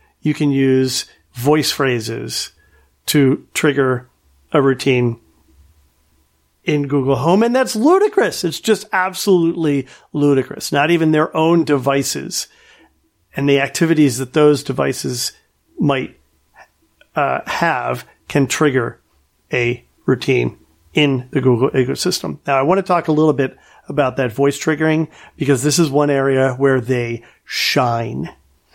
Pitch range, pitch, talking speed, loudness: 120-155 Hz, 140 Hz, 125 wpm, -17 LUFS